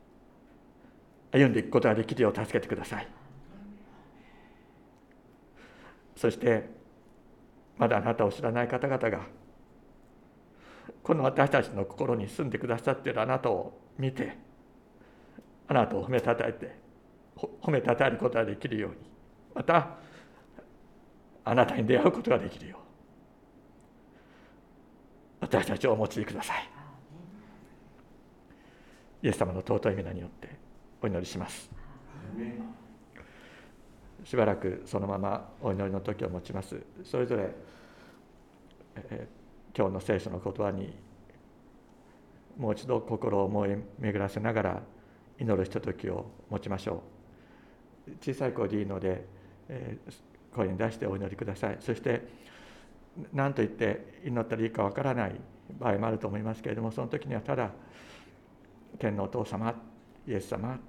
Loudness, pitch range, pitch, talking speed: -31 LUFS, 100-120 Hz, 110 Hz, 260 characters per minute